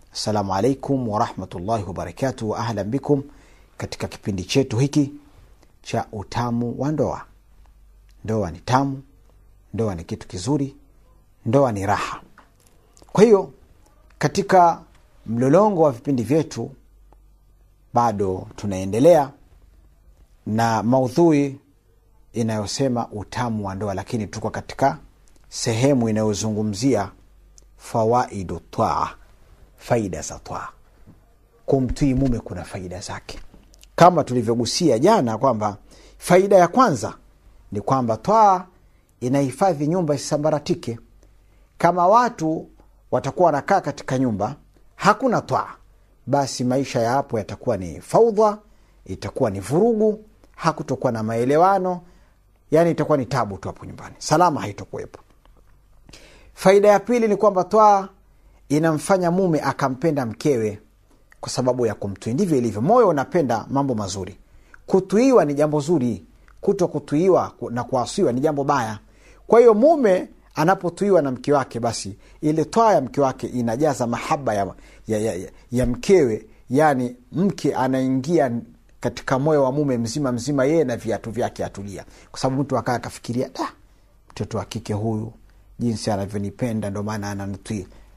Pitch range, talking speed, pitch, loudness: 105-145 Hz, 110 wpm, 120 Hz, -21 LUFS